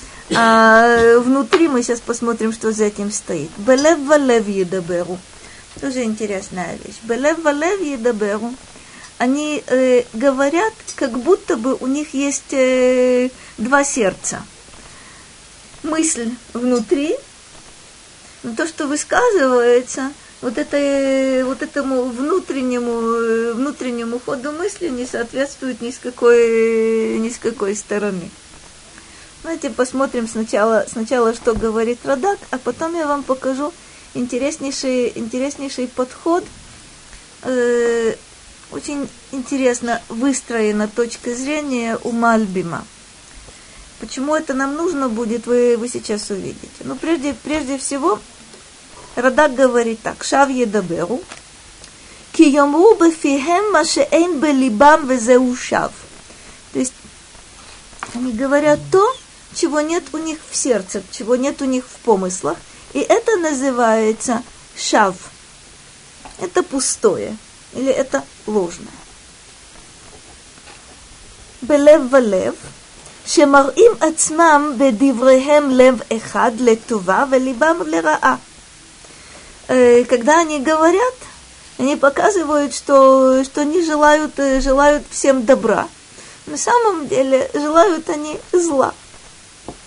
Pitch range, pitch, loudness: 235-295 Hz, 265 Hz, -16 LUFS